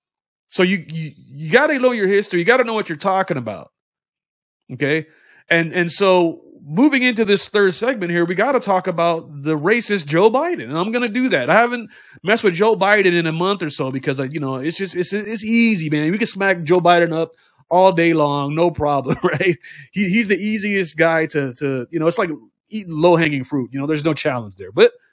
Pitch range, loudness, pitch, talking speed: 155-210 Hz, -18 LUFS, 175 Hz, 220 wpm